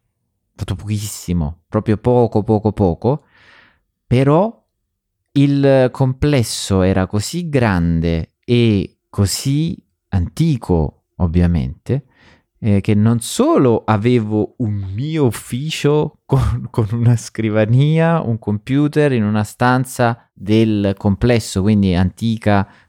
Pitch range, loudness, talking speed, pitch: 100-125 Hz, -17 LUFS, 95 wpm, 110 Hz